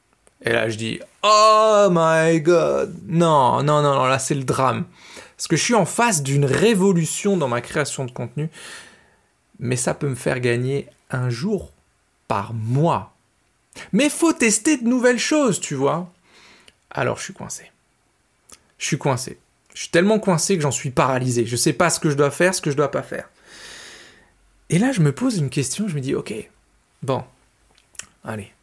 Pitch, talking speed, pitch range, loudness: 160 Hz, 190 wpm, 135-200 Hz, -19 LUFS